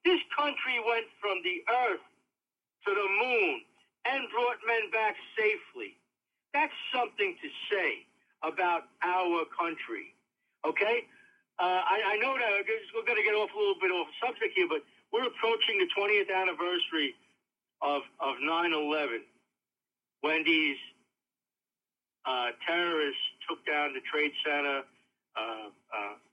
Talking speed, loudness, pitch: 130 wpm, -30 LUFS, 205 Hz